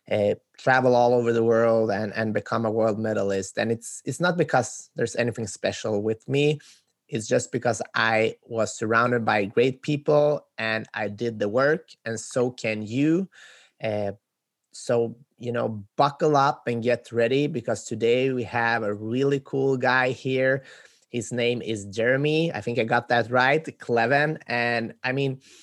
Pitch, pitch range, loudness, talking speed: 120 Hz, 110-135 Hz, -24 LUFS, 170 wpm